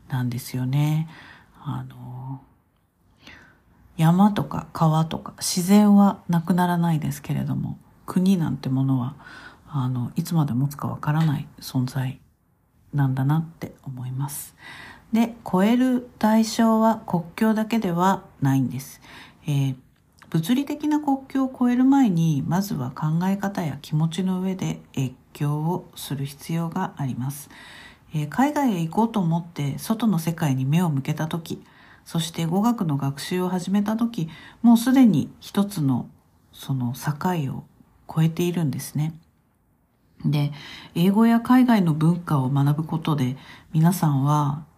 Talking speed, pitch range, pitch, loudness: 245 characters per minute, 140-195 Hz, 160 Hz, -23 LUFS